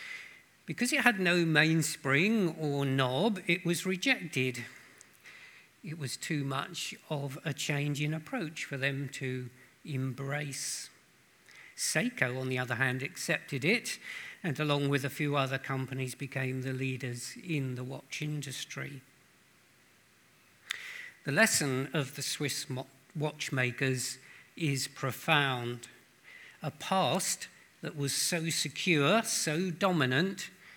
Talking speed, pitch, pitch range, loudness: 115 wpm, 145 Hz, 130-165 Hz, -32 LUFS